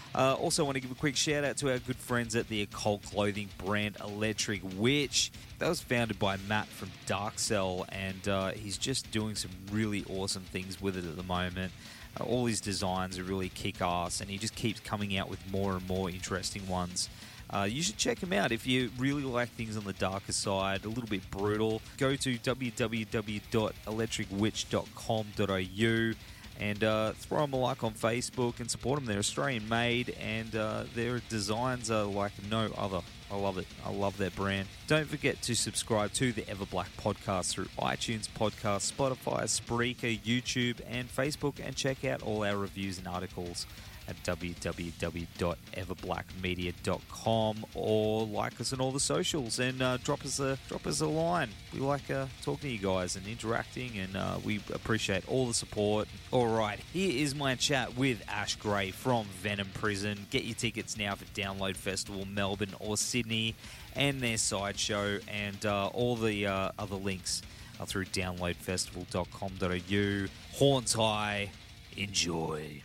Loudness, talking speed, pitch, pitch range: -33 LUFS, 170 wpm, 105 Hz, 95-120 Hz